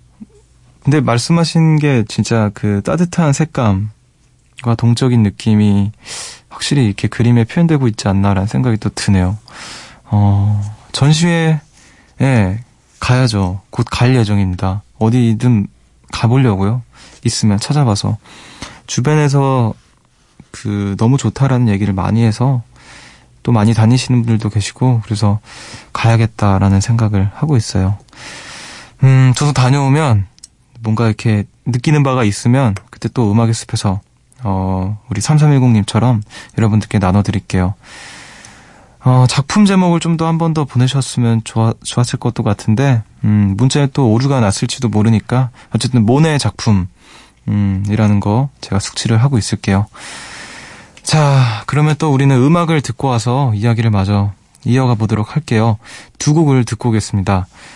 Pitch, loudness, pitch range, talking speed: 115 Hz, -14 LUFS, 105-130 Hz, 295 characters per minute